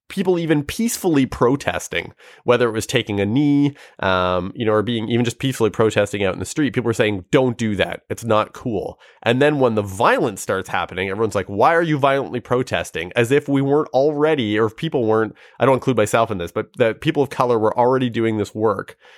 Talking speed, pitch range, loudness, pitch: 220 wpm, 110-140 Hz, -19 LUFS, 120 Hz